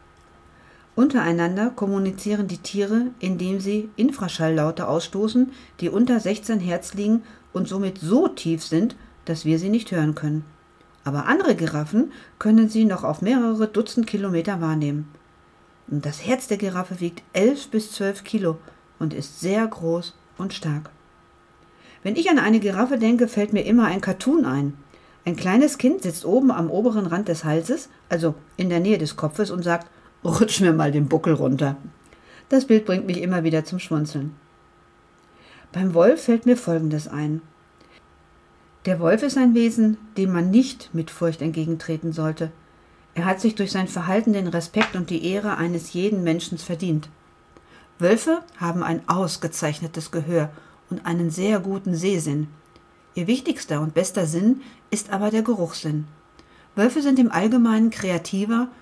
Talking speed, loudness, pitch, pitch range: 155 wpm, -22 LUFS, 185 Hz, 160-220 Hz